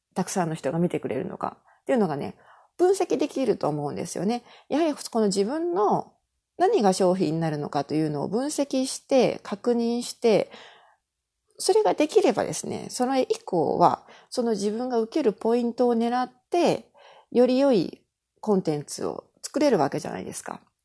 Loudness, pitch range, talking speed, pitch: -25 LUFS, 190-270 Hz, 335 characters per minute, 235 Hz